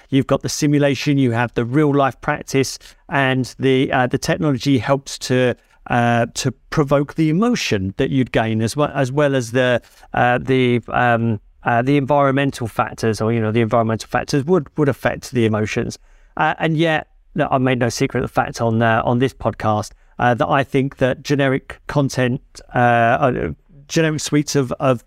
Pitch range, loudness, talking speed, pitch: 120-145 Hz, -18 LUFS, 185 wpm, 130 Hz